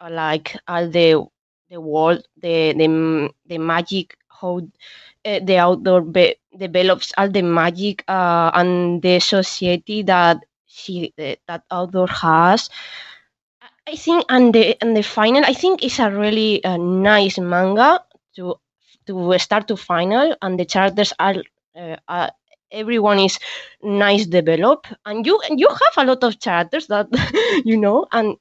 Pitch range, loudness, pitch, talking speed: 175-220 Hz, -17 LUFS, 190 Hz, 150 wpm